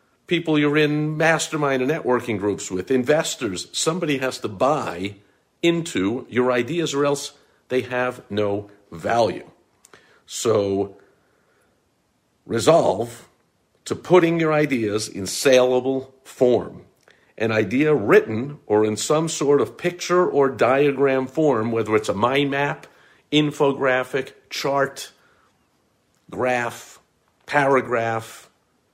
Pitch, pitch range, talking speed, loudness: 130 Hz, 115-150 Hz, 110 wpm, -21 LUFS